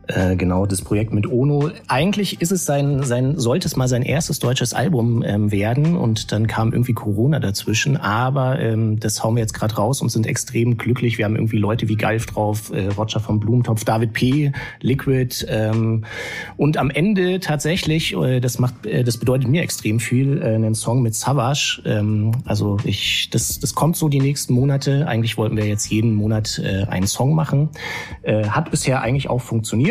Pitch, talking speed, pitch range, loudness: 120 Hz, 190 wpm, 110-140 Hz, -19 LUFS